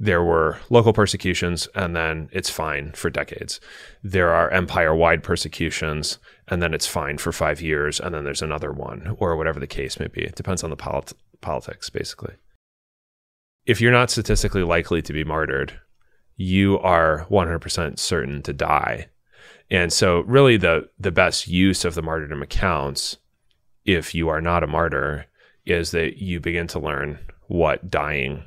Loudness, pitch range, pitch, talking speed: -22 LUFS, 80-95 Hz, 85 Hz, 165 wpm